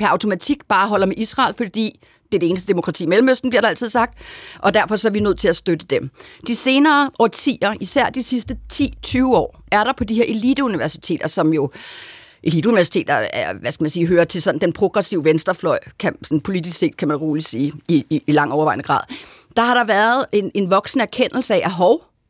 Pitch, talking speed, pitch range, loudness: 200 Hz, 215 wpm, 165-245 Hz, -18 LUFS